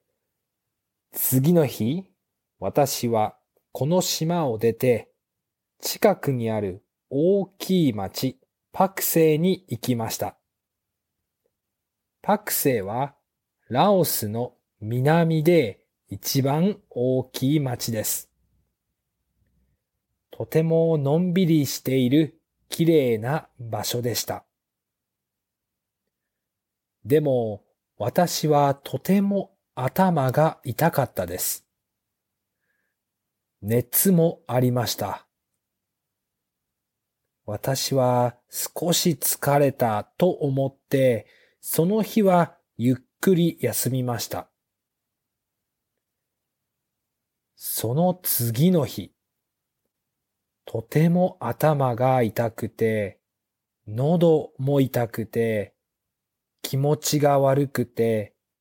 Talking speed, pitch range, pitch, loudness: 140 characters per minute, 115-160 Hz, 130 Hz, -23 LUFS